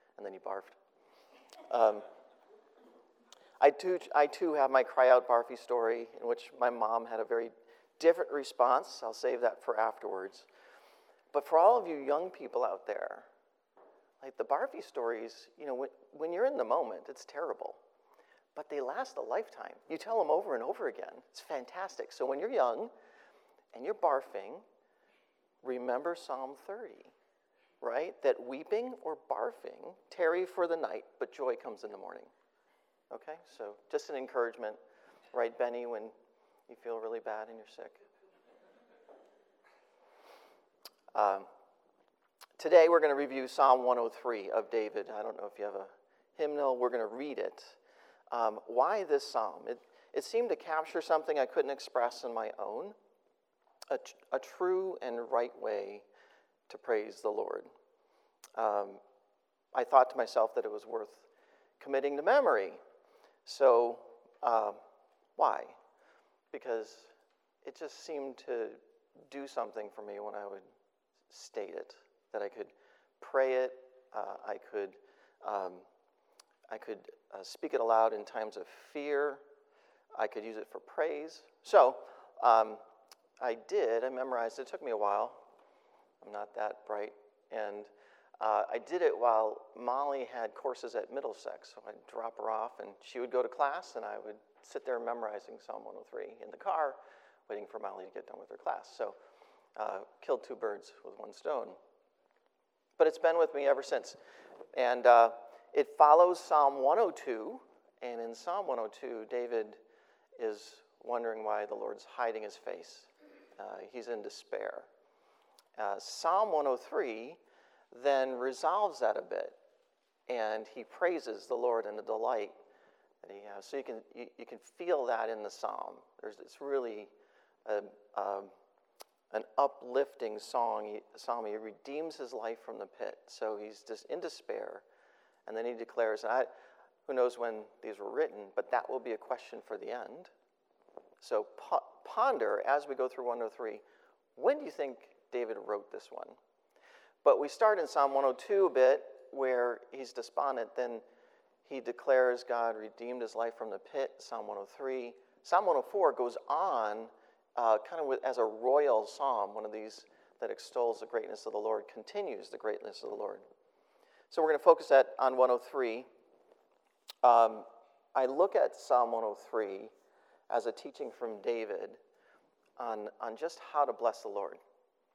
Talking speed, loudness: 160 wpm, -34 LUFS